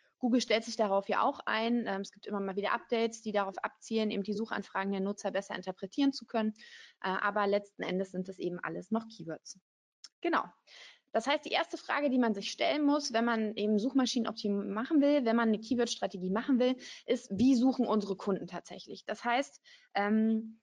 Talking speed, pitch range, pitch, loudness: 190 wpm, 200-250 Hz, 220 Hz, -32 LUFS